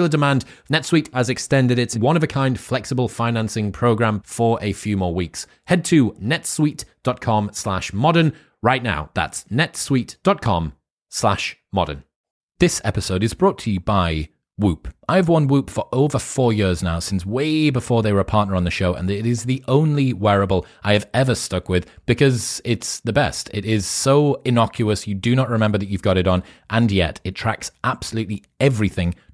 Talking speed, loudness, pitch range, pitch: 175 wpm, -20 LUFS, 100-135 Hz, 115 Hz